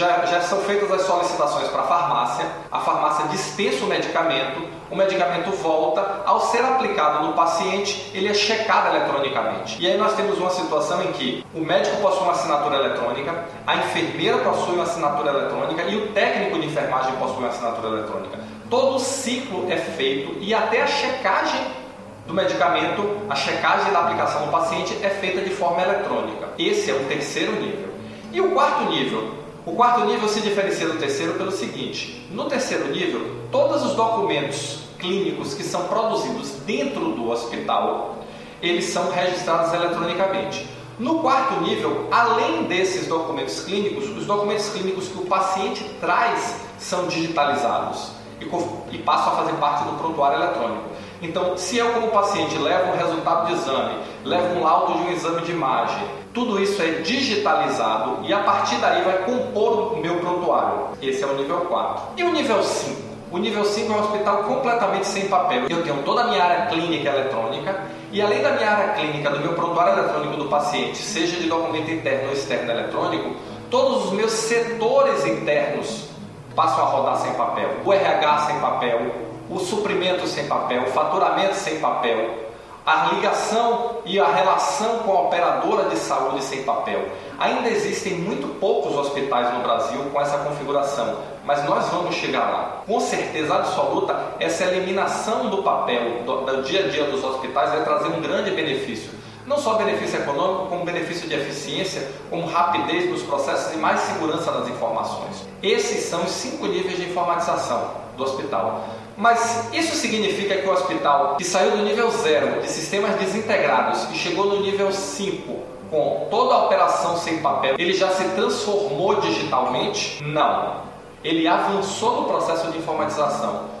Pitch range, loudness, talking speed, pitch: 150-205 Hz, -22 LUFS, 165 wpm, 175 Hz